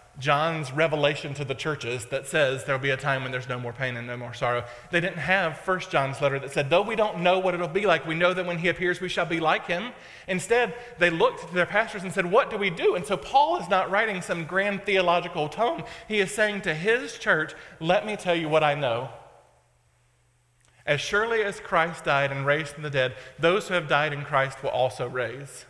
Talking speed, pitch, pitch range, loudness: 235 wpm, 165 Hz, 135-190 Hz, -25 LUFS